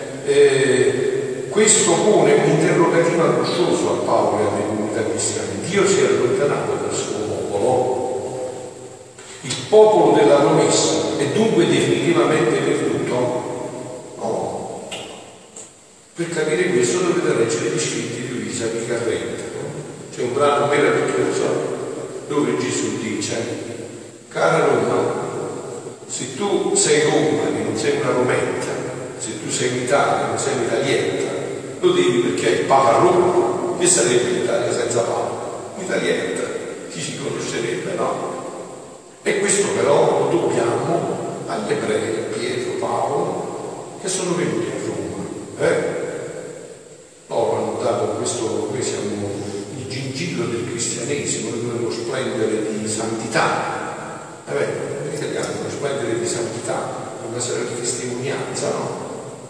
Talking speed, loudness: 130 wpm, -20 LUFS